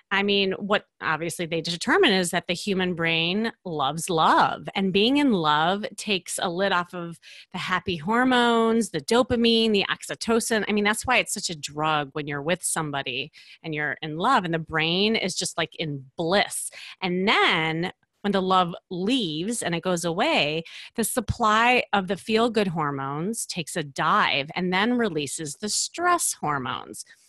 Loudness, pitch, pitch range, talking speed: -24 LUFS, 185 Hz, 165-215 Hz, 175 wpm